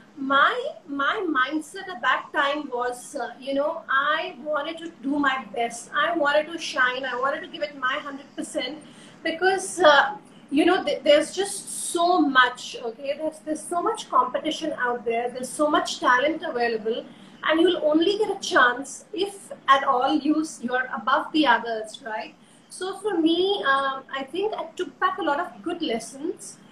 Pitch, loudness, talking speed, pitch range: 290 Hz, -24 LUFS, 175 wpm, 260-330 Hz